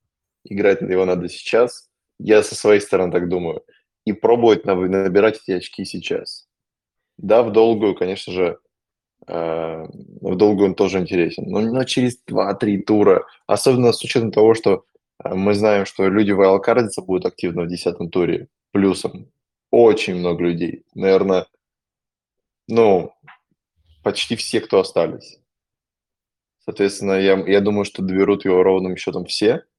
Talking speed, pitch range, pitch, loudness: 135 wpm, 90-105 Hz, 95 Hz, -18 LUFS